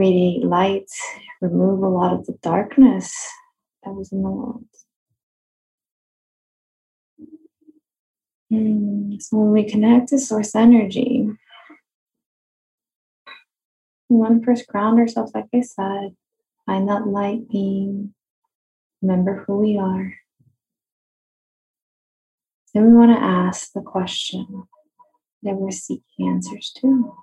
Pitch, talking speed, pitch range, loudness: 215 Hz, 110 wpm, 195-245 Hz, -19 LUFS